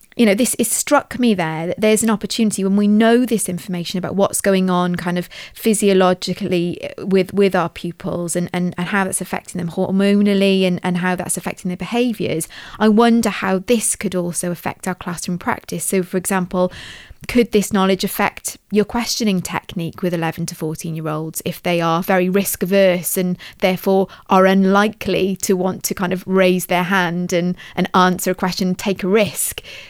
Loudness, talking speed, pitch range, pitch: -18 LUFS, 190 wpm, 180-200 Hz, 185 Hz